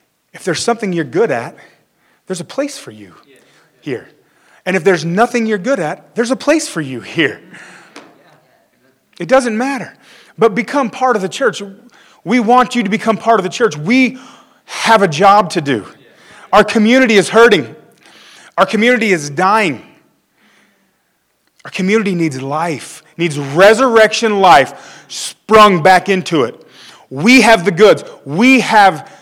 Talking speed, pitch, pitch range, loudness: 150 wpm, 215 Hz, 185-240 Hz, -12 LUFS